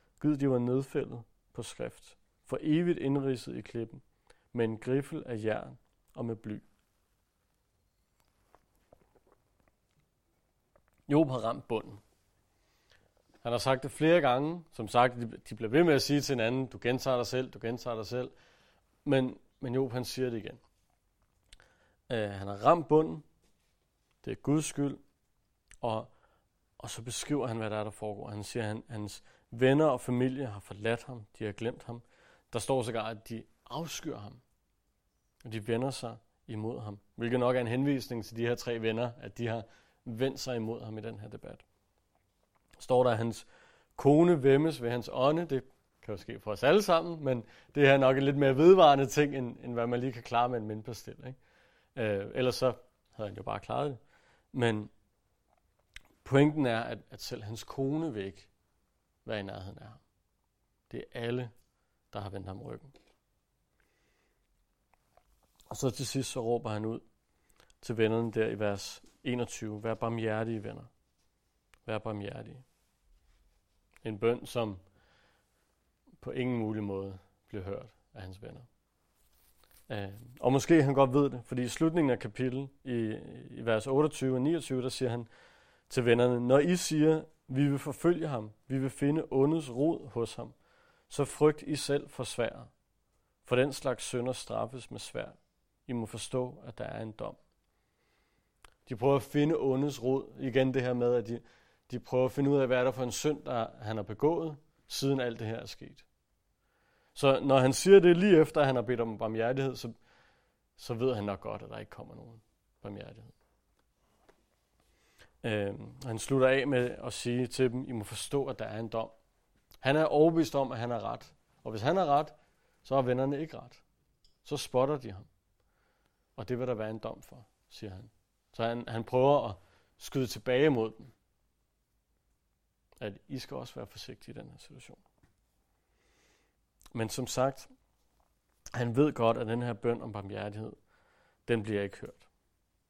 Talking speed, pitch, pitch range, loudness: 175 wpm, 120 Hz, 110-135 Hz, -31 LUFS